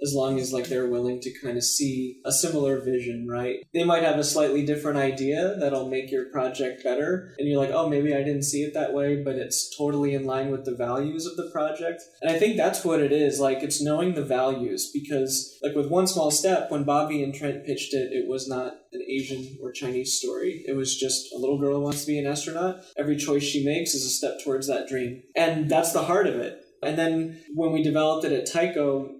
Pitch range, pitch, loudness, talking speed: 135-160 Hz, 145 Hz, -26 LUFS, 240 wpm